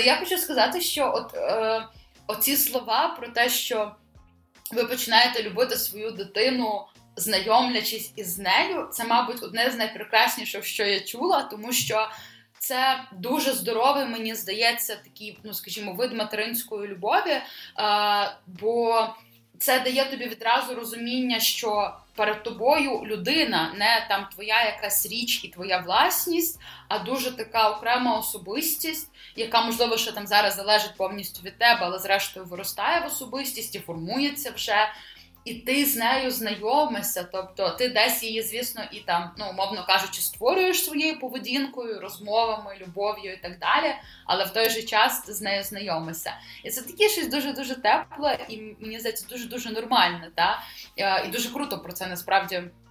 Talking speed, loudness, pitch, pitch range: 150 wpm, -25 LUFS, 220 Hz, 200-245 Hz